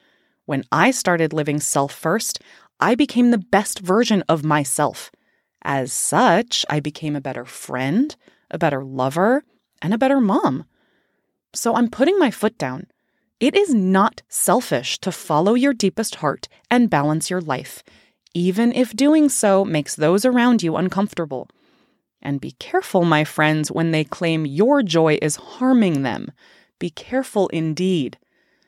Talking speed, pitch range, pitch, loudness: 150 wpm, 150-235 Hz, 185 Hz, -19 LUFS